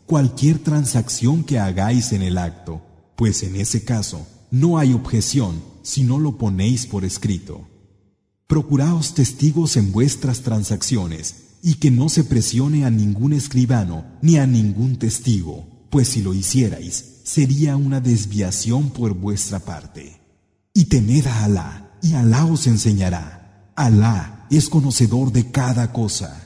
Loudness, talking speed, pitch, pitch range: -18 LUFS, 140 wpm, 115 Hz, 100-135 Hz